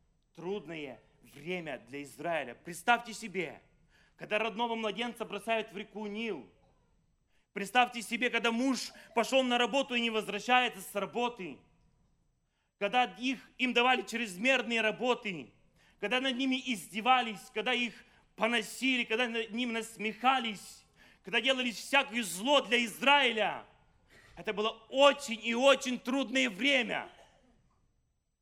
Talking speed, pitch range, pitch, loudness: 115 wpm, 210-250 Hz, 230 Hz, -31 LUFS